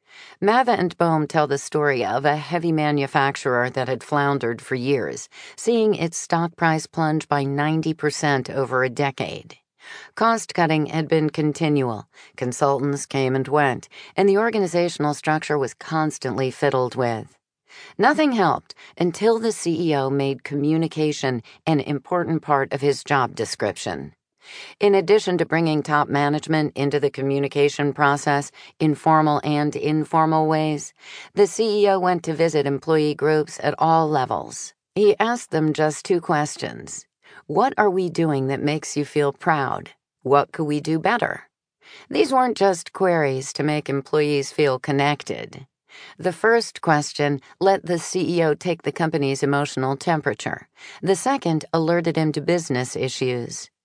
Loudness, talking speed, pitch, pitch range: -21 LUFS, 140 wpm, 150 Hz, 140-170 Hz